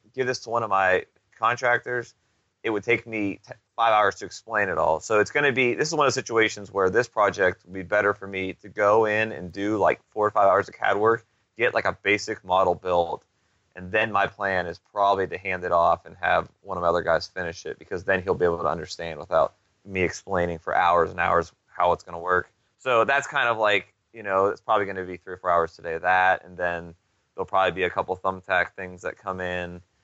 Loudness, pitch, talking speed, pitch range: -24 LUFS, 95 Hz, 250 wpm, 90-110 Hz